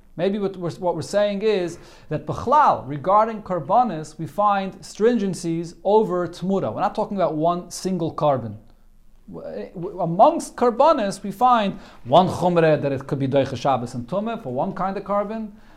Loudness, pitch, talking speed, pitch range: -21 LUFS, 180 Hz, 160 wpm, 155-205 Hz